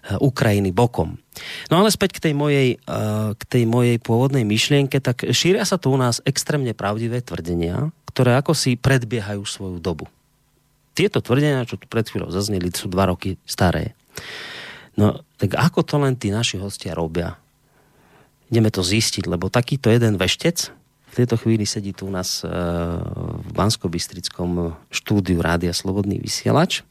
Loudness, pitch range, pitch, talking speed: -20 LUFS, 95-135 Hz, 115 Hz, 150 wpm